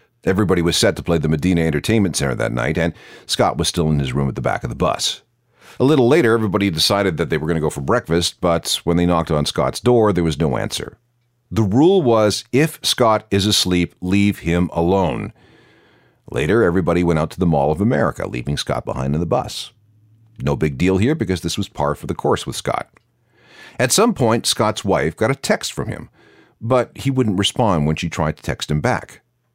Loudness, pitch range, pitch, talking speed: -18 LUFS, 85-110 Hz, 90 Hz, 215 wpm